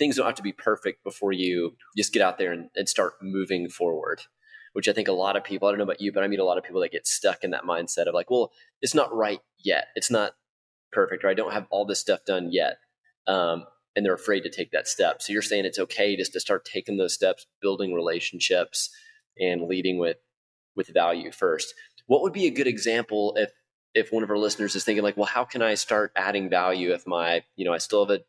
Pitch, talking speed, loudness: 105 Hz, 250 wpm, -26 LUFS